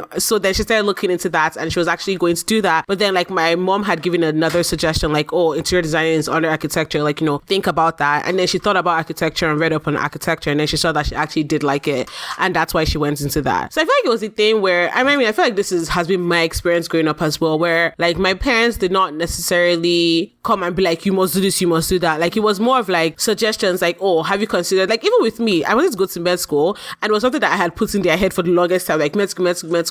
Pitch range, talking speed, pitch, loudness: 160-195 Hz, 305 wpm, 175 Hz, -17 LUFS